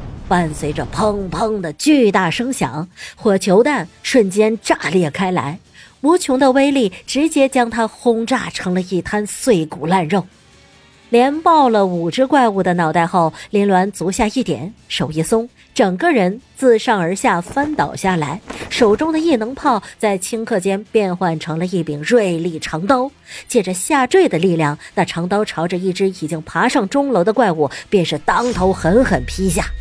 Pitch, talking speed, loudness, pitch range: 200 Hz, 240 characters per minute, -16 LUFS, 175-245 Hz